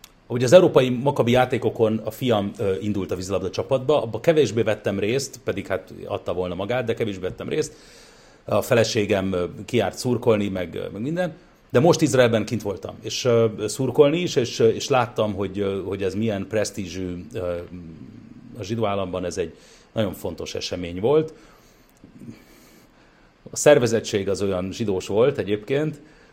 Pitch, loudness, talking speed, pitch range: 110 Hz, -22 LUFS, 150 wpm, 95-125 Hz